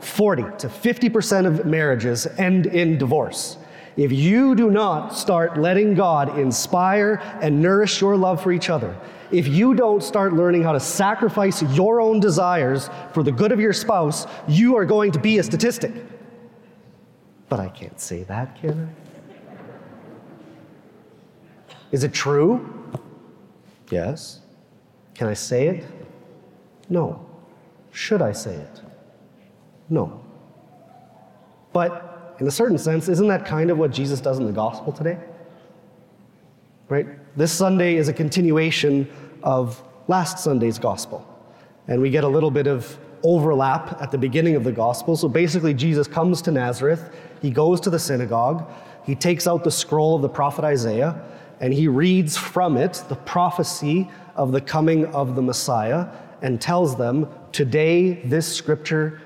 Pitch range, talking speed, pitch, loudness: 145-180 Hz, 150 wpm, 160 Hz, -20 LUFS